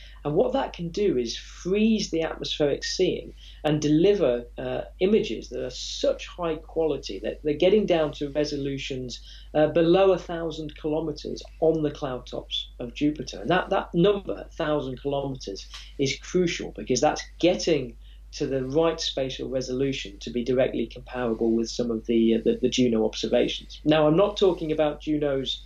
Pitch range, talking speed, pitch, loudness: 125-165 Hz, 165 wpm, 150 Hz, -25 LUFS